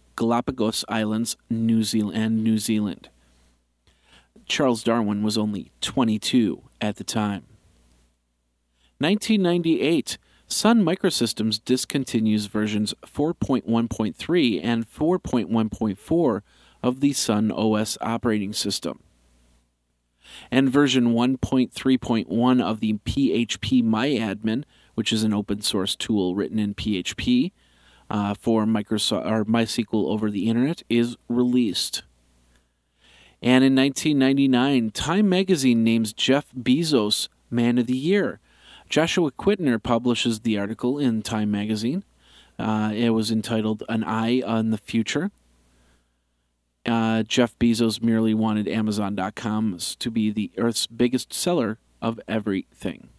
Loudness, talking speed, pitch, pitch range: -23 LUFS, 110 wpm, 110 Hz, 105-125 Hz